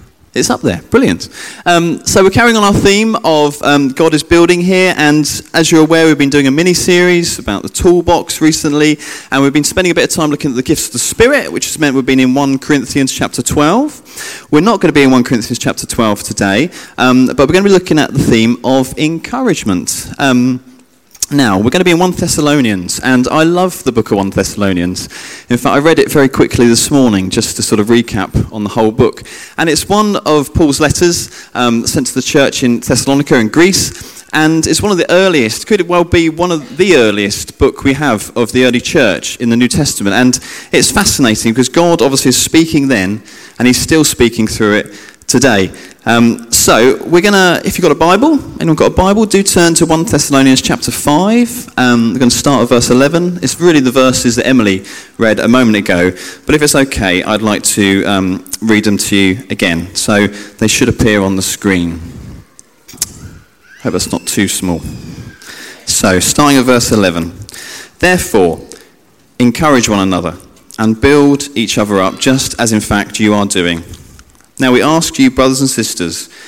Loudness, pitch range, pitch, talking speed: -10 LUFS, 110-160 Hz, 130 Hz, 205 wpm